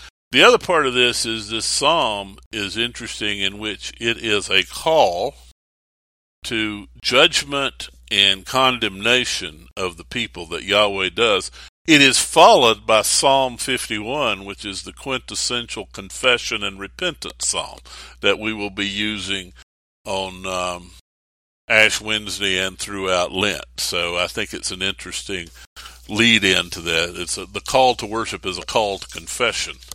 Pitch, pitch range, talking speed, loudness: 100 Hz, 90-115 Hz, 145 wpm, -18 LUFS